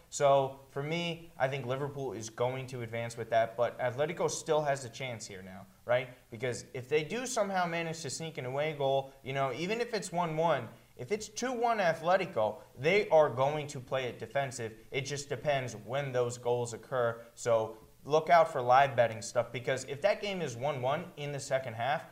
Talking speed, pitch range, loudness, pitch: 205 wpm, 120-160 Hz, -32 LUFS, 135 Hz